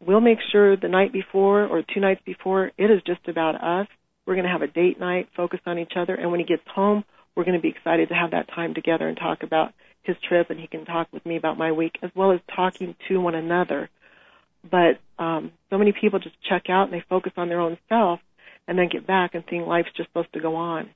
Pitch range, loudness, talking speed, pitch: 170-190 Hz, -23 LUFS, 255 wpm, 180 Hz